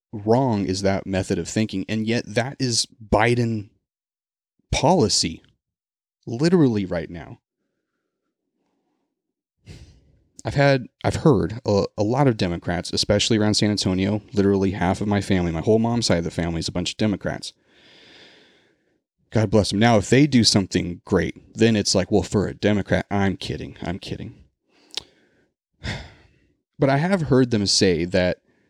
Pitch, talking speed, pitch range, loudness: 105 Hz, 150 wpm, 95-115 Hz, -21 LUFS